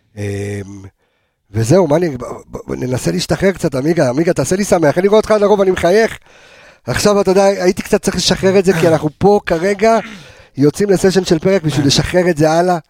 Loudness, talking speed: -13 LUFS, 215 wpm